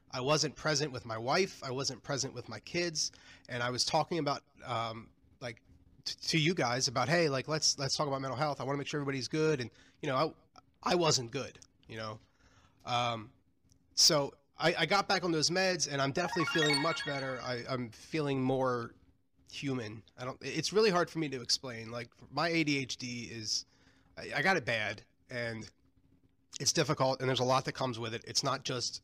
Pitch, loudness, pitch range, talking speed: 130 Hz, -32 LUFS, 120-155 Hz, 205 wpm